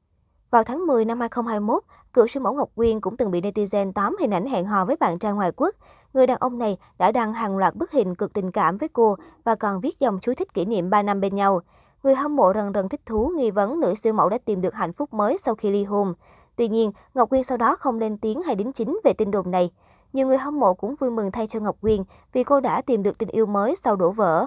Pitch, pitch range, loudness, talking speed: 220 Hz, 200-255 Hz, -22 LUFS, 270 wpm